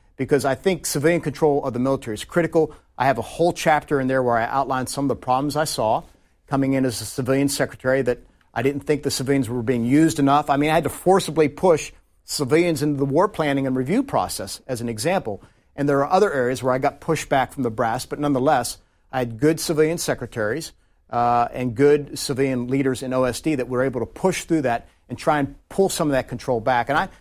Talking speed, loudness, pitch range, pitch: 230 wpm, -21 LUFS, 125-150 Hz, 140 Hz